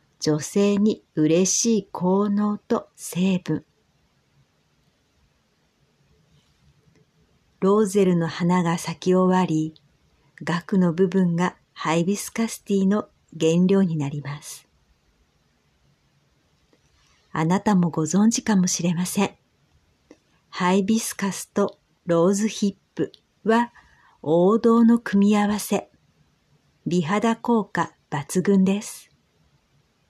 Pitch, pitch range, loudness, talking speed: 185 Hz, 165-205 Hz, -22 LUFS, 175 characters per minute